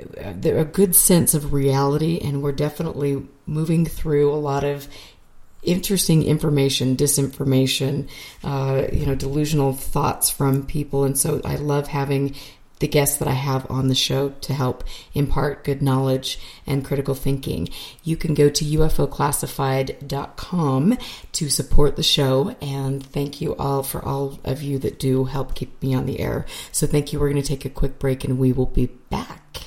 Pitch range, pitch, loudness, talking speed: 135-150 Hz, 140 Hz, -21 LUFS, 170 wpm